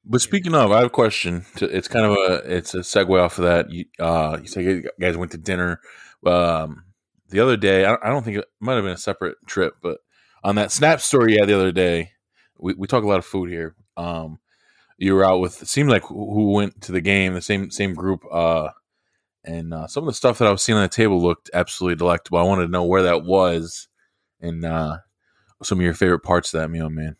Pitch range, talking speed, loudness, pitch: 85-100 Hz, 245 wpm, -20 LUFS, 90 Hz